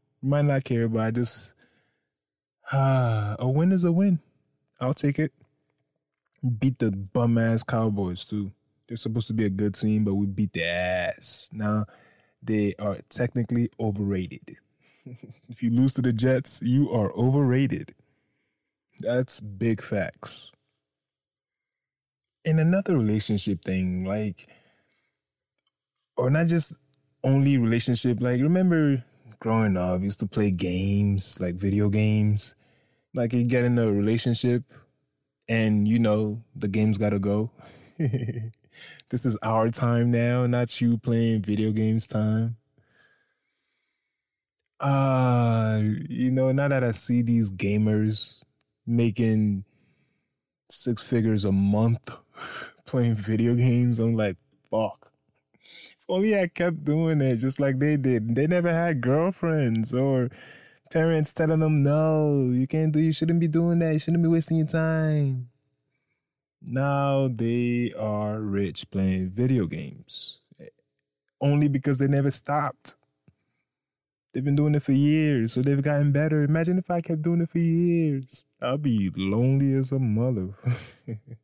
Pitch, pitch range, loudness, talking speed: 125 Hz, 110-140 Hz, -25 LUFS, 140 wpm